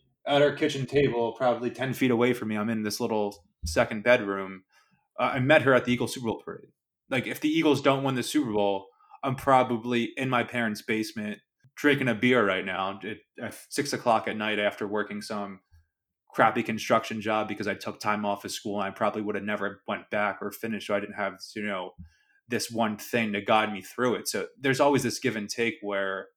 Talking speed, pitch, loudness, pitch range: 220 wpm, 110 Hz, -27 LUFS, 105-125 Hz